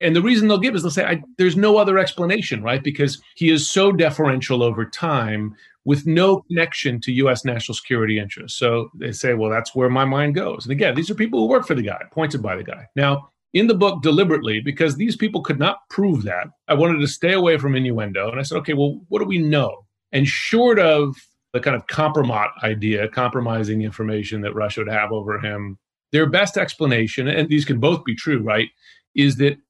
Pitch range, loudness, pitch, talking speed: 115-165 Hz, -19 LUFS, 140 Hz, 220 wpm